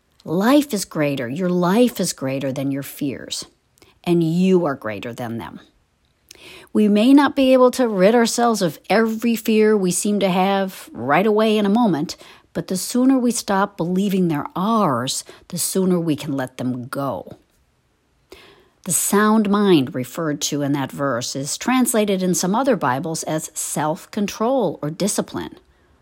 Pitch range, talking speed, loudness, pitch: 150-215 Hz, 160 wpm, -19 LUFS, 185 Hz